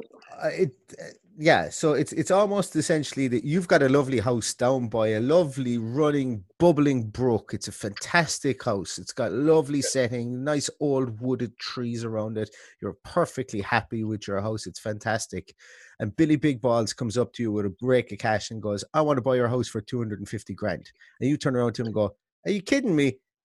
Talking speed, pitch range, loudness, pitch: 210 wpm, 110-145 Hz, -26 LUFS, 125 Hz